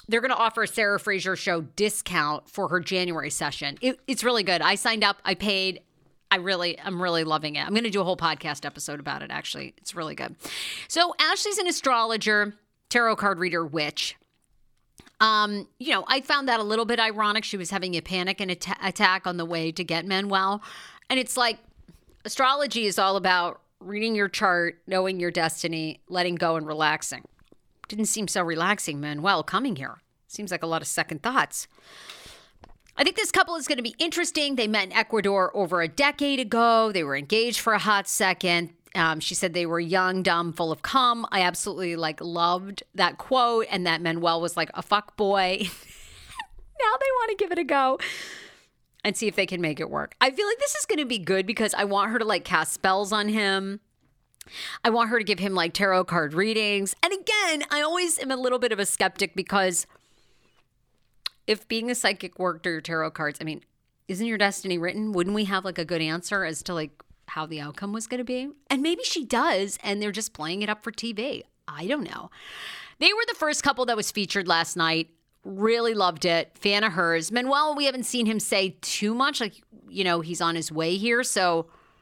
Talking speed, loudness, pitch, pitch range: 210 wpm, -25 LUFS, 200 Hz, 175-230 Hz